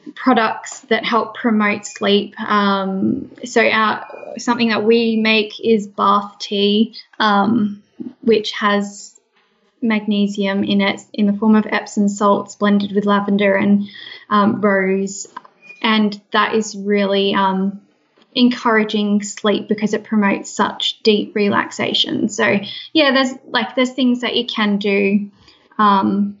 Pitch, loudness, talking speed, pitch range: 210 Hz, -17 LUFS, 130 wpm, 205-225 Hz